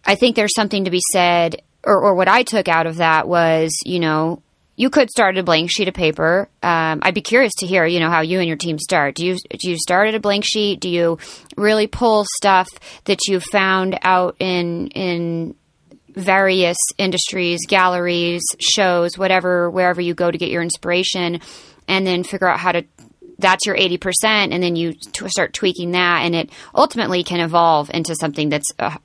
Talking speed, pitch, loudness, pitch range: 200 wpm, 180 Hz, -17 LUFS, 170-195 Hz